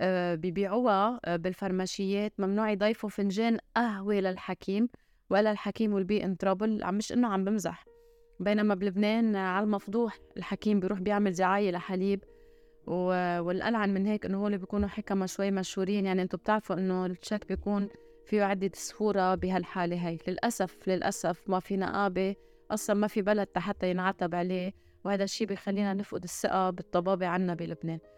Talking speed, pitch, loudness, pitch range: 140 wpm, 195 Hz, -30 LUFS, 185-210 Hz